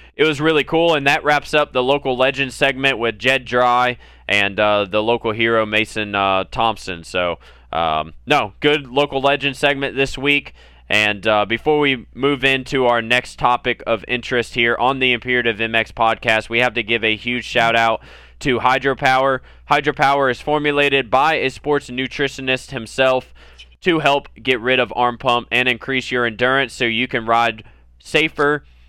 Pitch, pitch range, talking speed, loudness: 125 Hz, 115-135 Hz, 170 wpm, -17 LUFS